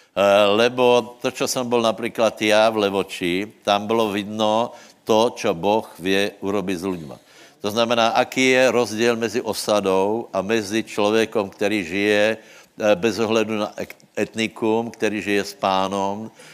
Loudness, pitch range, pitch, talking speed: -20 LUFS, 100-115 Hz, 110 Hz, 140 wpm